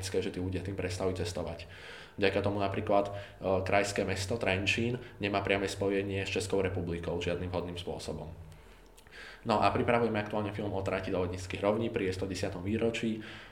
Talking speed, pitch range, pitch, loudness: 160 wpm, 90-105 Hz, 95 Hz, -32 LUFS